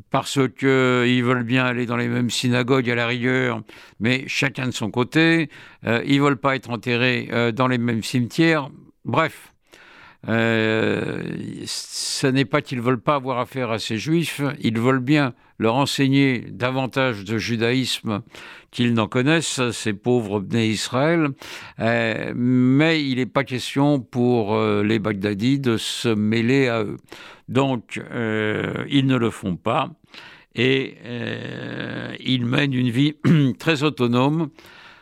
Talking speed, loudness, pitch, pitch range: 145 wpm, -21 LUFS, 125 Hz, 115-140 Hz